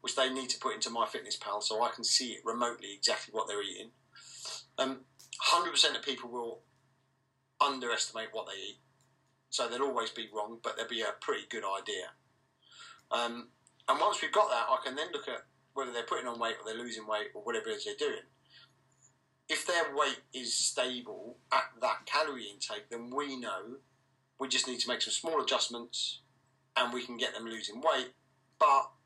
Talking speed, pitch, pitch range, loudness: 195 wpm, 130 Hz, 120-135 Hz, -33 LUFS